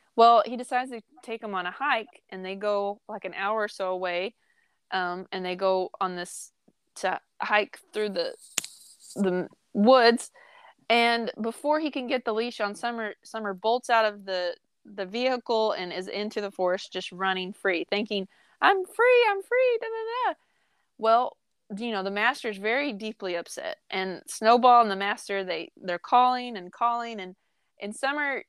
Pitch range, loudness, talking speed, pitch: 195-250 Hz, -26 LUFS, 175 wpm, 220 Hz